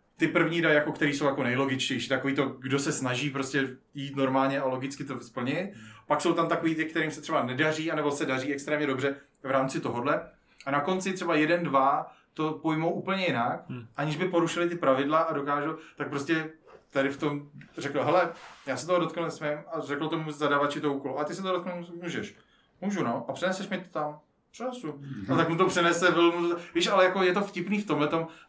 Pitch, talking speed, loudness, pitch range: 155 Hz, 210 wpm, -28 LUFS, 140-170 Hz